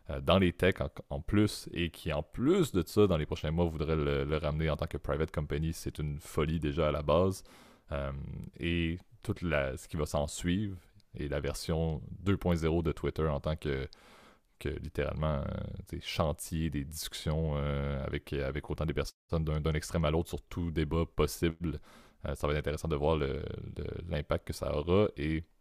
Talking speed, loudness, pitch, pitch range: 195 wpm, -33 LUFS, 80 Hz, 75-85 Hz